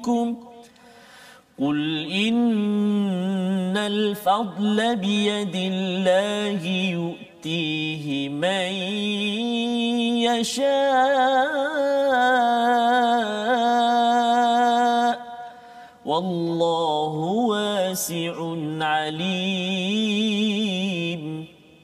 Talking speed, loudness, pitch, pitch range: 30 wpm, -22 LUFS, 210 Hz, 185-240 Hz